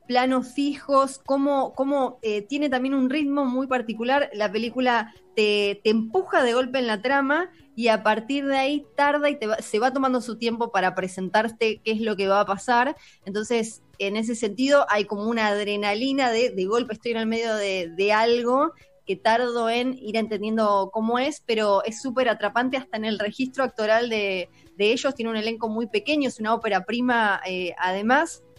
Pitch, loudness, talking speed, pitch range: 230 Hz, -24 LUFS, 195 wpm, 215-265 Hz